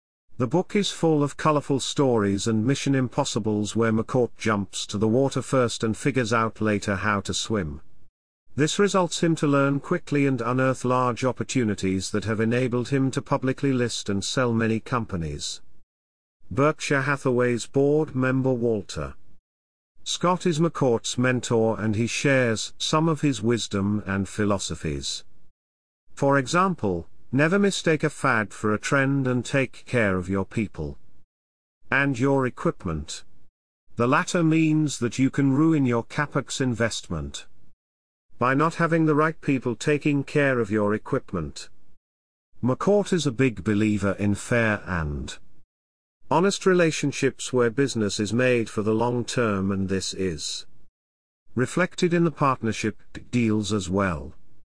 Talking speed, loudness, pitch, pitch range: 140 wpm, -24 LUFS, 120 Hz, 100-140 Hz